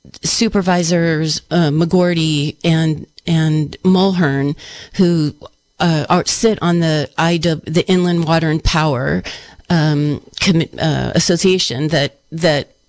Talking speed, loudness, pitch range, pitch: 110 wpm, -15 LUFS, 155-175 Hz, 165 Hz